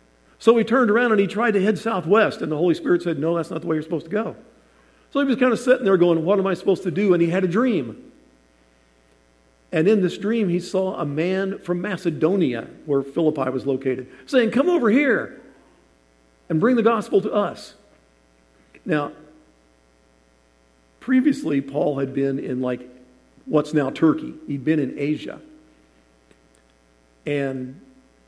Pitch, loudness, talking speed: 155 Hz, -21 LUFS, 175 wpm